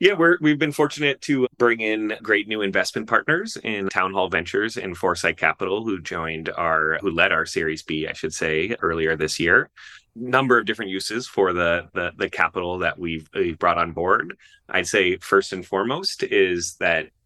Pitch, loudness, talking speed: 110 Hz, -22 LUFS, 190 wpm